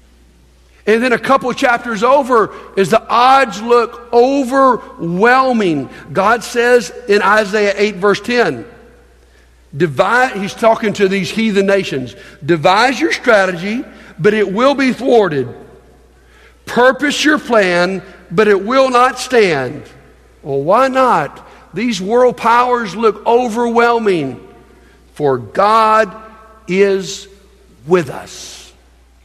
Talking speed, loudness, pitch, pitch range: 115 wpm, -13 LUFS, 215 Hz, 185-240 Hz